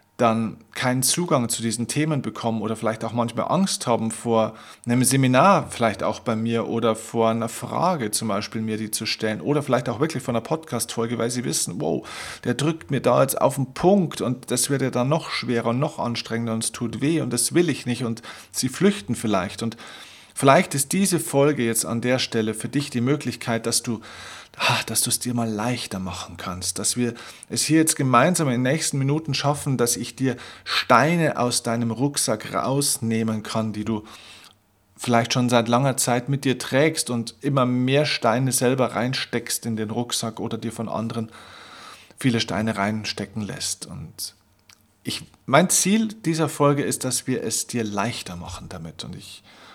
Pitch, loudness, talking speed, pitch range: 120 Hz, -23 LUFS, 190 wpm, 110-135 Hz